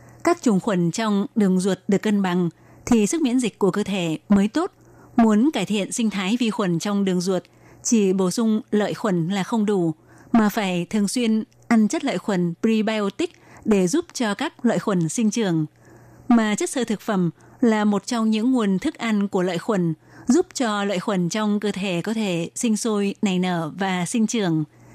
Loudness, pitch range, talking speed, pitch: -22 LUFS, 185-225 Hz, 200 wpm, 205 Hz